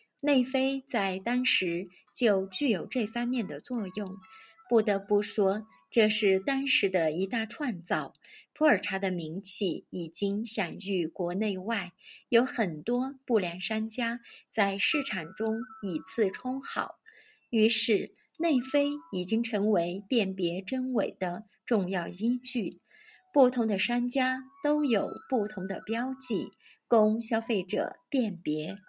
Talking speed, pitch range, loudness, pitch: 185 characters per minute, 195-250 Hz, -29 LUFS, 220 Hz